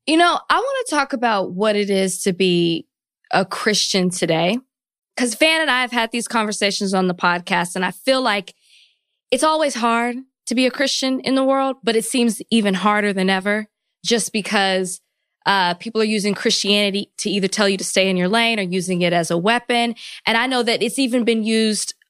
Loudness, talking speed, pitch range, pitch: -18 LUFS, 210 wpm, 190-245 Hz, 220 Hz